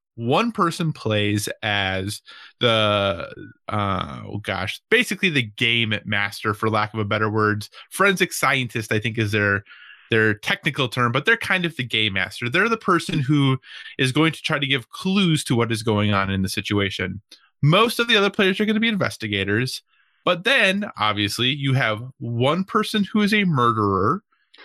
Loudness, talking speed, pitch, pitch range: -21 LUFS, 180 wpm, 120 Hz, 105-175 Hz